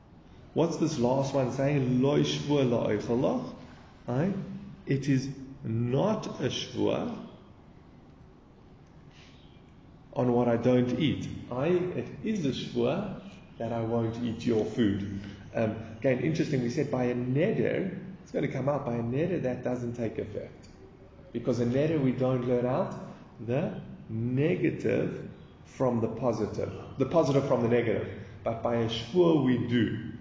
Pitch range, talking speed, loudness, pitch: 115-140 Hz, 135 wpm, -29 LUFS, 125 Hz